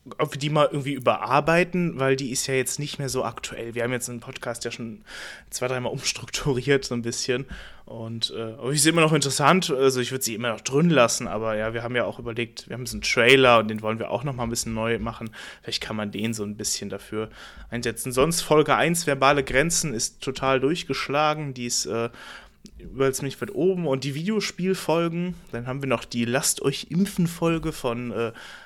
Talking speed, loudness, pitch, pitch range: 210 wpm, -24 LUFS, 130 Hz, 115-145 Hz